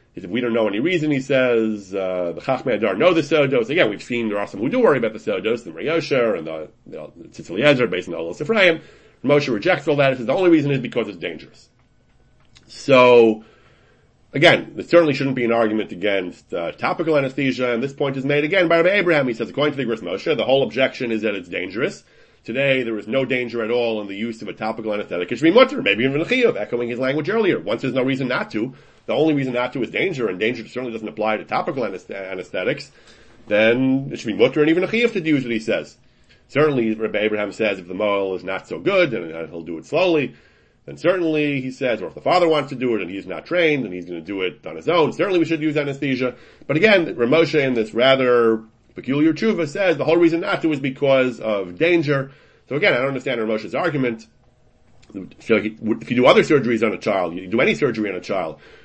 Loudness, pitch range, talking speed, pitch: -19 LUFS, 110-150 Hz, 240 wpm, 130 Hz